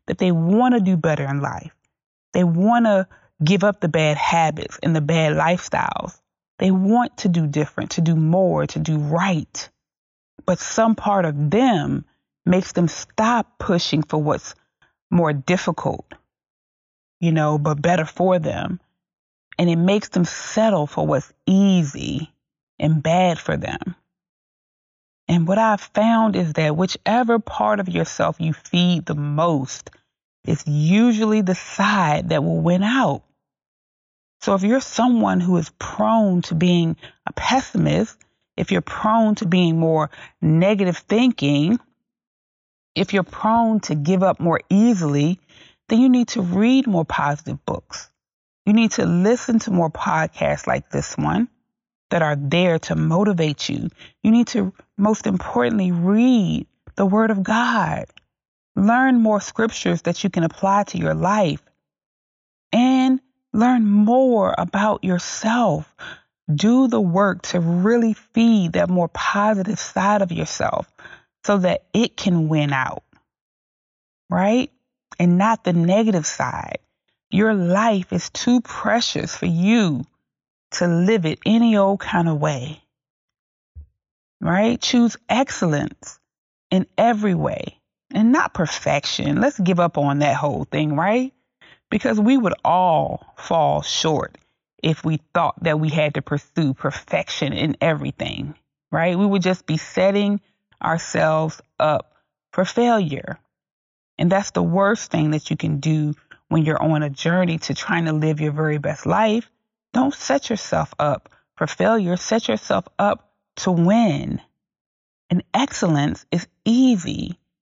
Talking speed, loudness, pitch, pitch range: 145 wpm, -20 LUFS, 185 Hz, 155-220 Hz